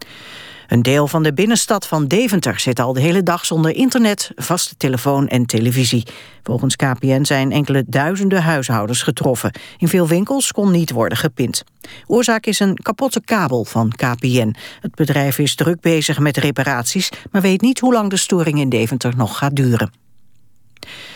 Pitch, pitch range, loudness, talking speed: 145 Hz, 125-190 Hz, -16 LUFS, 165 wpm